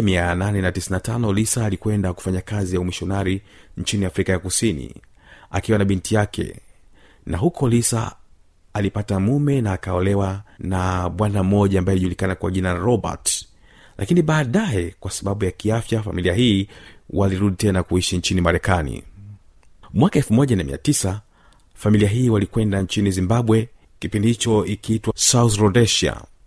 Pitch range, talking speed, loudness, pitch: 90-110 Hz, 125 wpm, -20 LUFS, 100 Hz